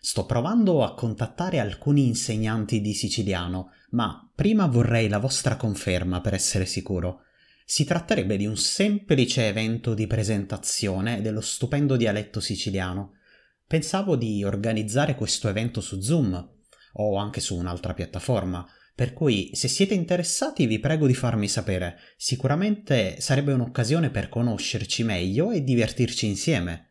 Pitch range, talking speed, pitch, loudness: 100-135 Hz, 135 wpm, 110 Hz, -25 LUFS